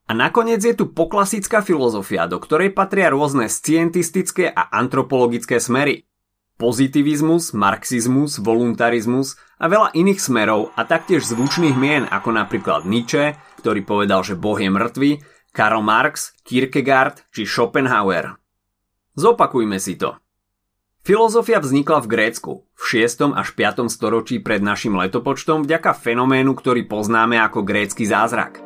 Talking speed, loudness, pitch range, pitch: 130 wpm, -18 LUFS, 105-155 Hz, 130 Hz